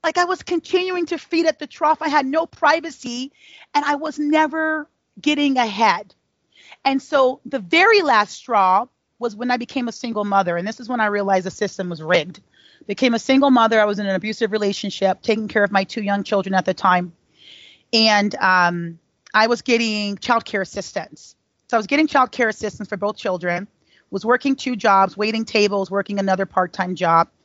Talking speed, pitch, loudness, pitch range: 195 wpm, 225 Hz, -19 LUFS, 195-280 Hz